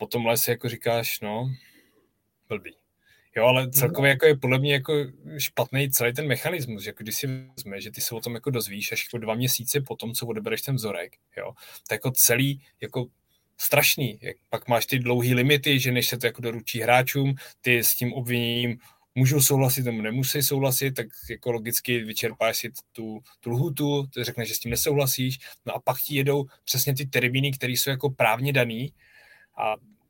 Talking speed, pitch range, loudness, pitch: 195 wpm, 115-140 Hz, -24 LUFS, 125 Hz